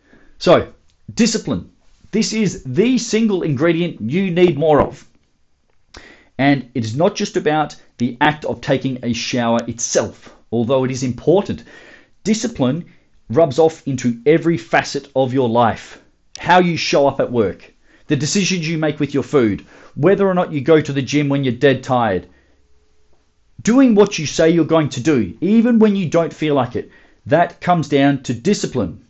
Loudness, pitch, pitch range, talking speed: -17 LUFS, 150 Hz, 125-175 Hz, 170 wpm